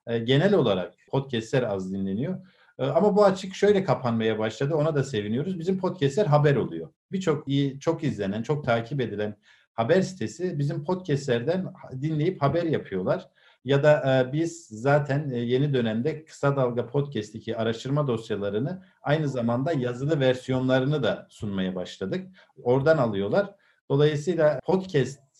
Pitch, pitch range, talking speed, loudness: 140 Hz, 120-160 Hz, 130 wpm, -26 LUFS